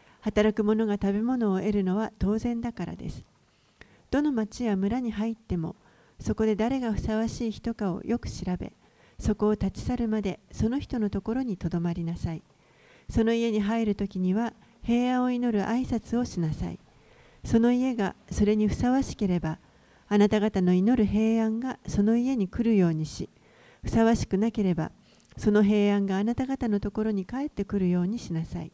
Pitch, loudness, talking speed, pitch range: 215 Hz, -27 LUFS, 335 characters per minute, 195-230 Hz